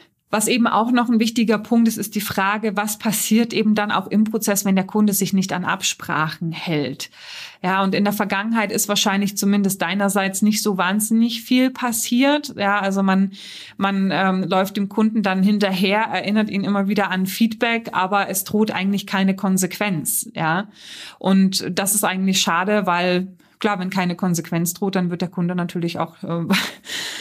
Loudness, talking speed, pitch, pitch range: -20 LUFS, 180 wpm, 200 Hz, 190-215 Hz